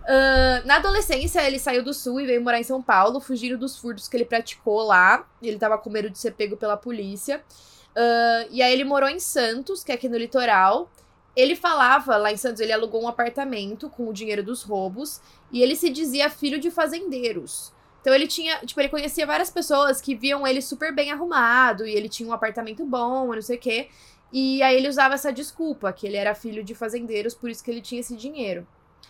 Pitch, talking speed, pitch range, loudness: 250 Hz, 215 wpm, 230-280 Hz, -22 LUFS